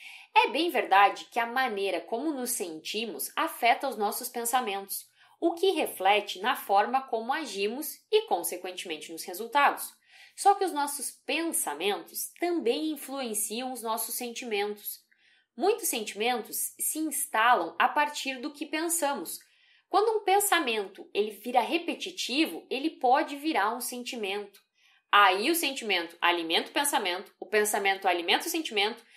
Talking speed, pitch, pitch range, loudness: 135 wpm, 270 Hz, 215-340 Hz, -28 LUFS